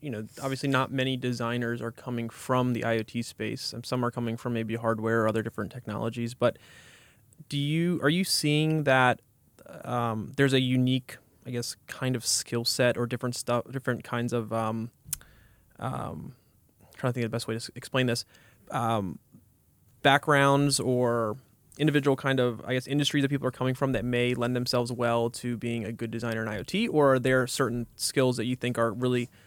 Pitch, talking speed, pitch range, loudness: 120 Hz, 195 wpm, 115-130 Hz, -28 LUFS